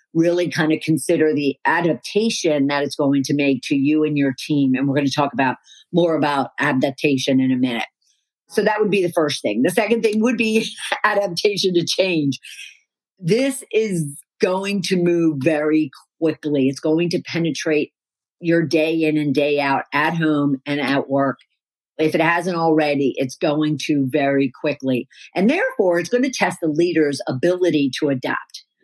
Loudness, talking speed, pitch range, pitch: -19 LUFS, 175 wpm, 140-175 Hz, 155 Hz